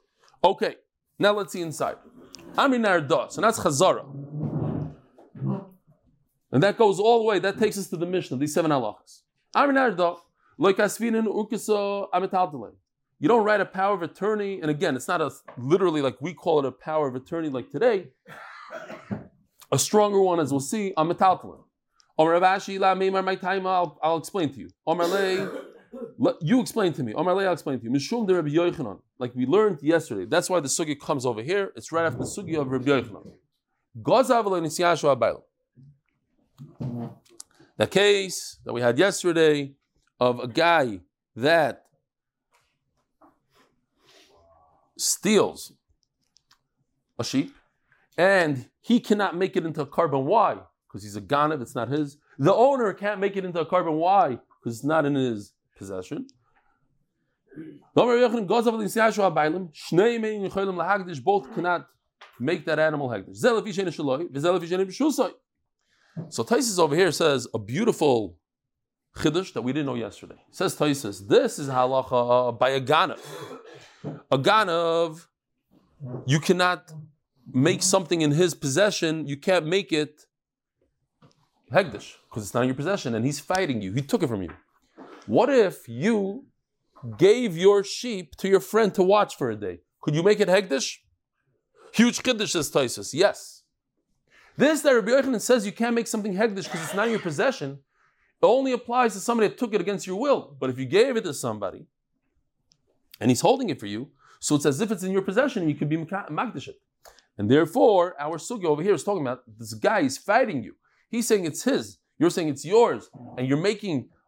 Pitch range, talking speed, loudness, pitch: 140-205 Hz, 155 wpm, -24 LUFS, 175 Hz